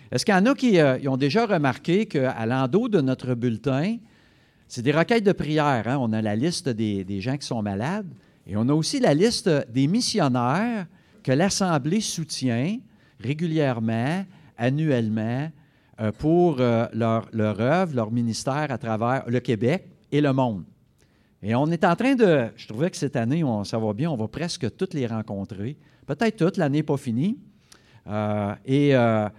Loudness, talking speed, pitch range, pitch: -24 LUFS, 180 wpm, 115-170 Hz, 135 Hz